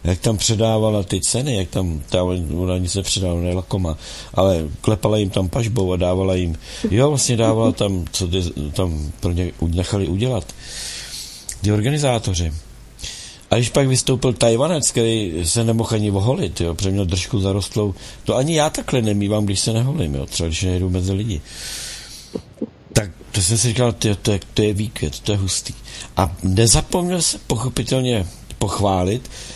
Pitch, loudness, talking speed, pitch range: 100 Hz, -19 LUFS, 155 wpm, 90-115 Hz